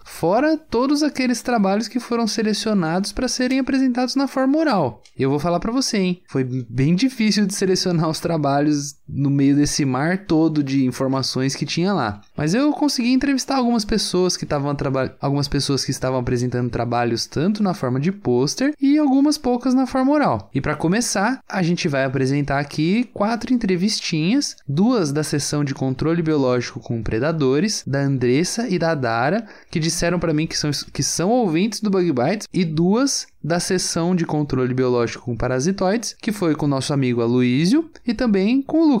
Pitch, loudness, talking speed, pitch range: 170 Hz, -20 LUFS, 180 wpm, 140-230 Hz